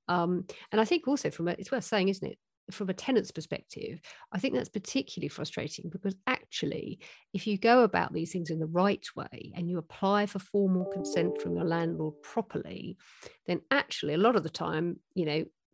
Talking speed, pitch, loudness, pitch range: 200 wpm, 190 Hz, -31 LUFS, 170-215 Hz